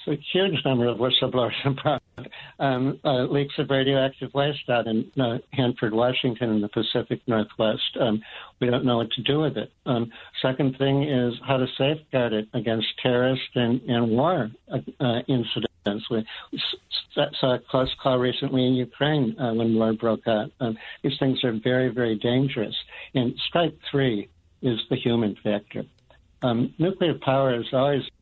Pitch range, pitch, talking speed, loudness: 115-135 Hz, 125 Hz, 165 wpm, -24 LUFS